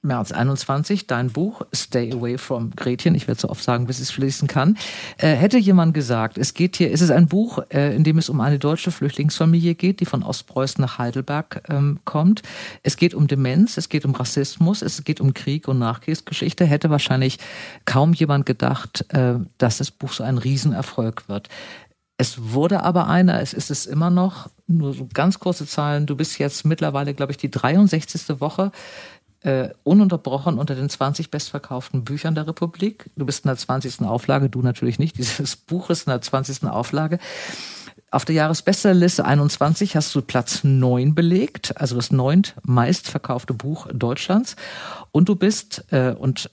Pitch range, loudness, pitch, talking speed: 130-170 Hz, -20 LUFS, 145 Hz, 180 wpm